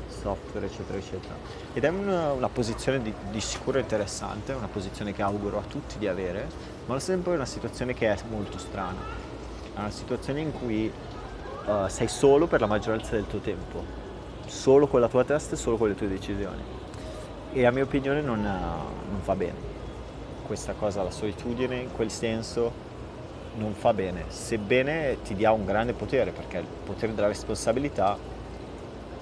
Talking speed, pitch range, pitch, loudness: 175 wpm, 100-125 Hz, 110 Hz, -28 LUFS